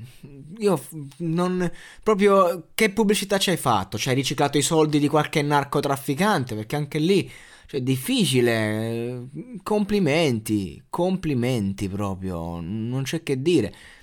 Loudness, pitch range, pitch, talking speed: -23 LUFS, 120-180 Hz, 145 Hz, 130 wpm